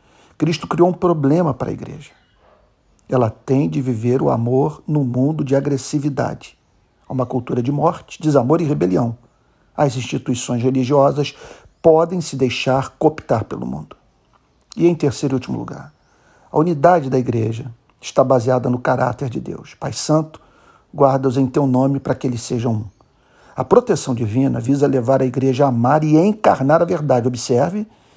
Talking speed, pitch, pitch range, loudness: 160 wpm, 135 Hz, 130-150 Hz, -18 LUFS